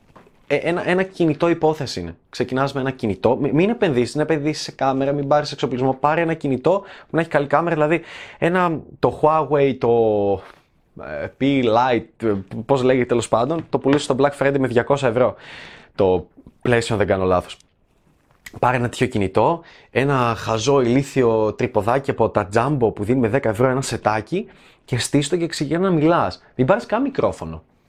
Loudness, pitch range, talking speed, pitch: -20 LUFS, 115-150 Hz, 175 wpm, 135 Hz